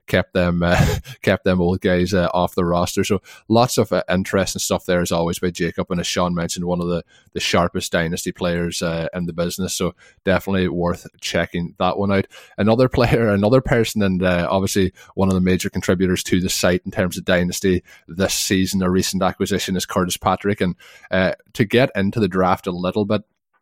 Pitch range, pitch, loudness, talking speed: 90-95 Hz, 90 Hz, -20 LUFS, 205 wpm